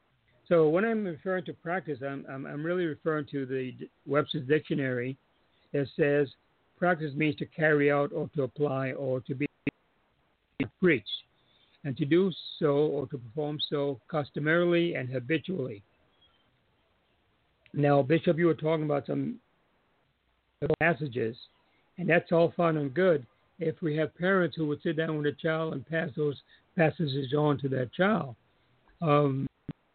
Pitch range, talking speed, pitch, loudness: 135-165 Hz, 150 wpm, 150 Hz, -29 LUFS